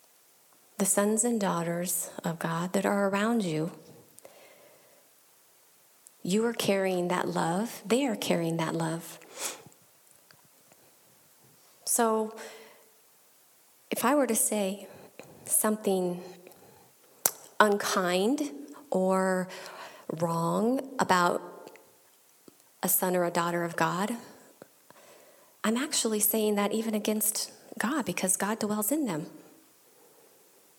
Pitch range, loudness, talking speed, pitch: 180-230 Hz, -28 LUFS, 95 wpm, 200 Hz